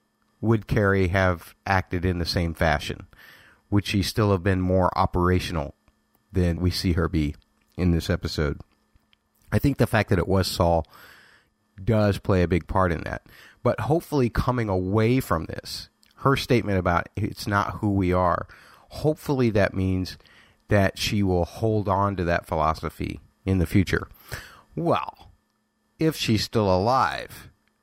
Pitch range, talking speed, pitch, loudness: 85-105 Hz, 155 wpm, 95 Hz, -24 LUFS